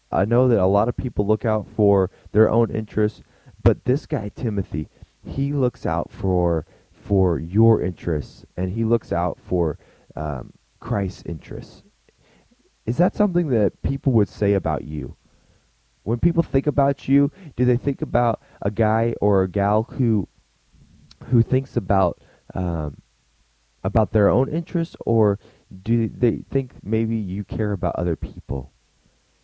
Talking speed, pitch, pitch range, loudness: 150 wpm, 110 Hz, 95-120 Hz, -22 LUFS